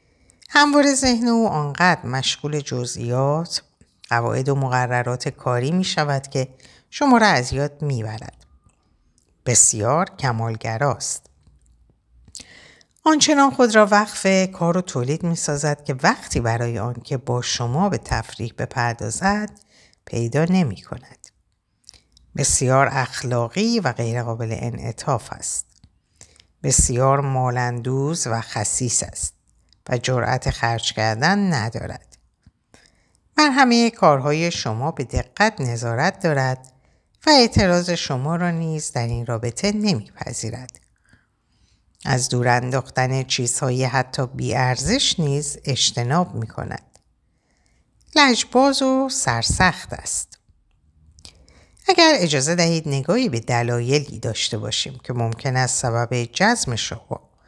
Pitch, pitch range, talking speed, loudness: 130 Hz, 120-170 Hz, 110 wpm, -20 LUFS